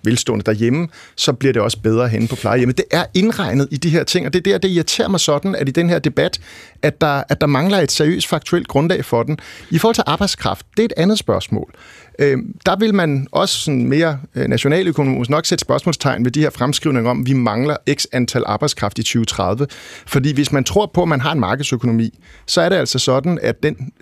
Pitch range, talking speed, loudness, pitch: 125-170 Hz, 230 wpm, -17 LUFS, 145 Hz